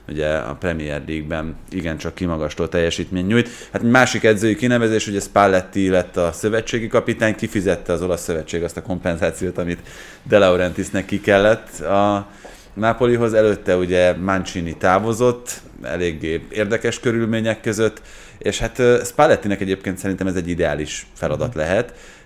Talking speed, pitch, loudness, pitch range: 135 wpm, 95 Hz, -19 LUFS, 85-110 Hz